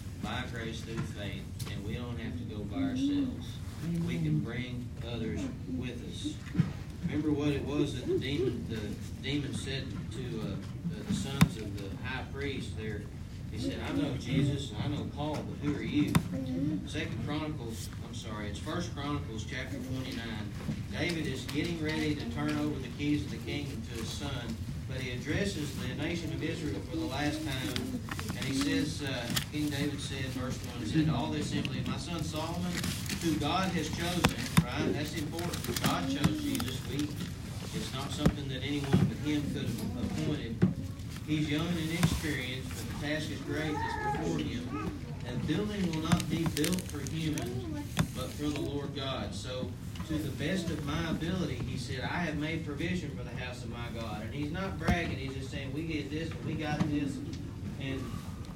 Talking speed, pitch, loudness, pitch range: 185 wpm, 130 Hz, -34 LUFS, 115-150 Hz